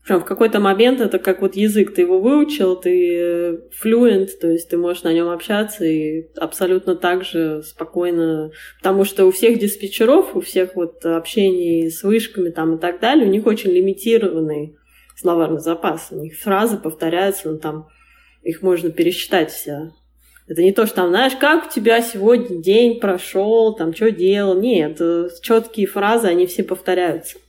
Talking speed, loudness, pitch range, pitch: 170 wpm, -17 LUFS, 165-210 Hz, 185 Hz